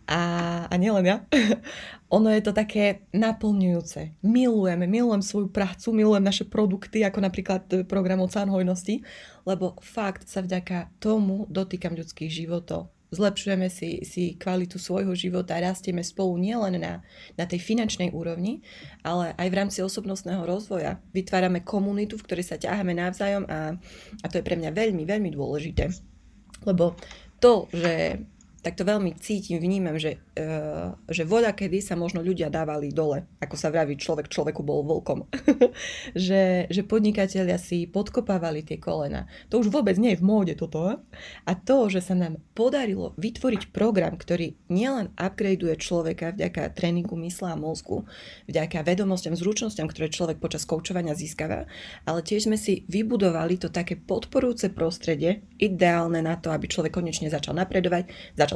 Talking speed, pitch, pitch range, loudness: 150 wpm, 185 Hz, 170-205 Hz, -26 LUFS